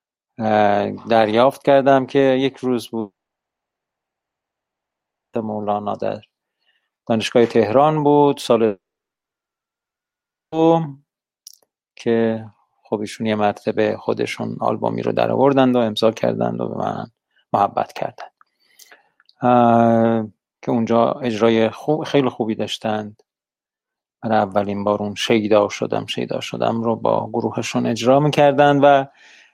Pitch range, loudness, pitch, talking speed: 105-130 Hz, -18 LUFS, 115 Hz, 100 wpm